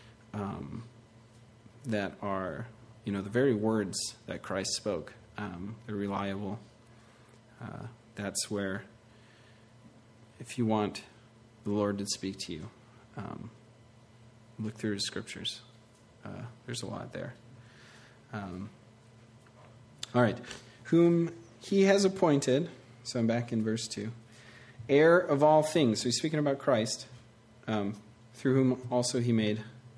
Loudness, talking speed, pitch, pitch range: -31 LUFS, 130 wpm, 115 Hz, 110-125 Hz